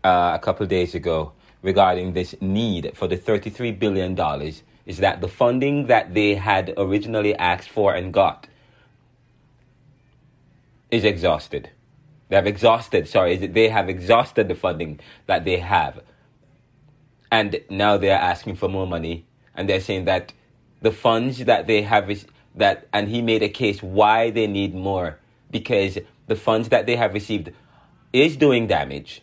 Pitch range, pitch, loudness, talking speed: 95-125 Hz, 105 Hz, -21 LUFS, 165 wpm